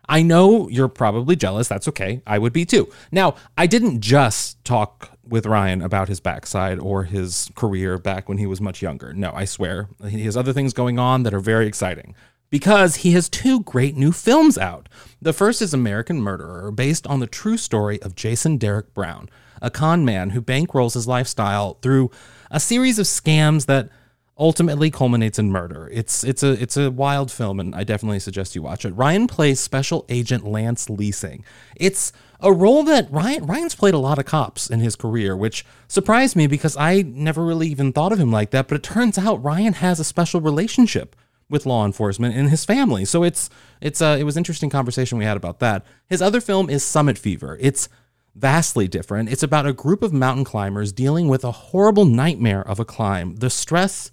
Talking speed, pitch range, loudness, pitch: 200 wpm, 105-160 Hz, -19 LUFS, 130 Hz